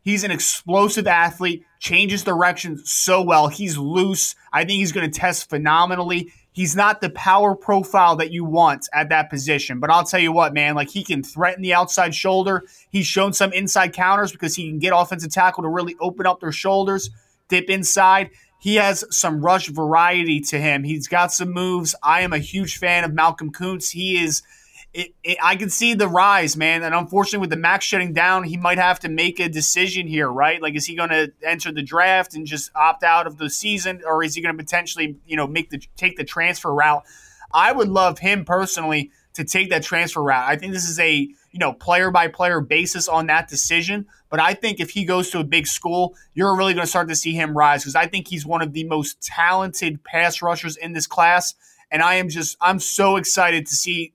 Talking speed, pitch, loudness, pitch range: 220 wpm, 175 Hz, -18 LUFS, 155-185 Hz